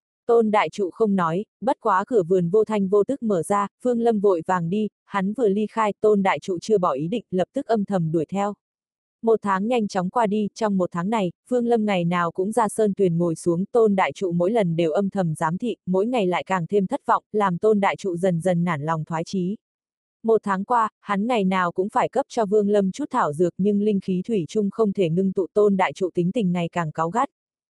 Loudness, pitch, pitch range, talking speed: -22 LUFS, 200 Hz, 185-220 Hz, 255 wpm